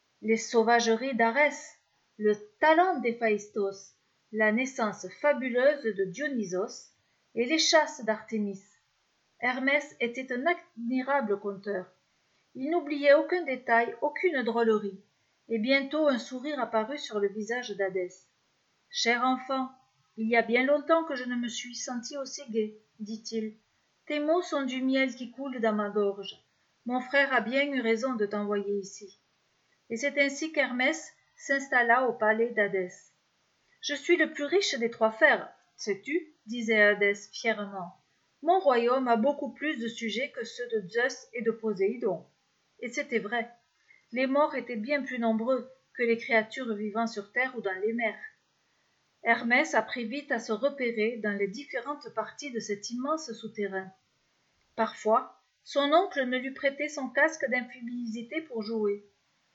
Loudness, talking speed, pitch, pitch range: -29 LUFS, 150 wpm, 240 Hz, 220-280 Hz